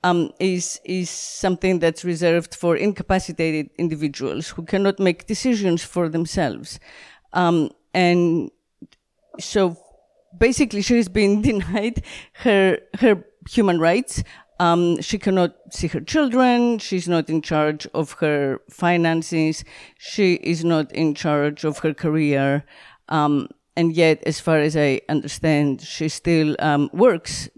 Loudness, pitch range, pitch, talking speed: -20 LUFS, 155-190 Hz, 170 Hz, 130 wpm